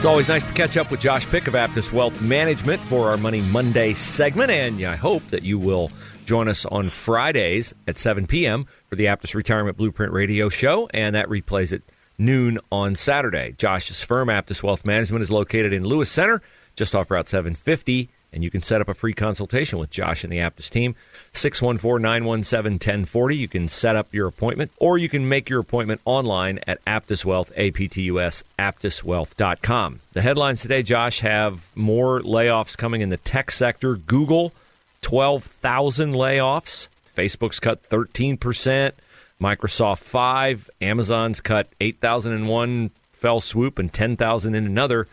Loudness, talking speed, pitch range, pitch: -21 LUFS, 165 wpm, 100-125 Hz, 110 Hz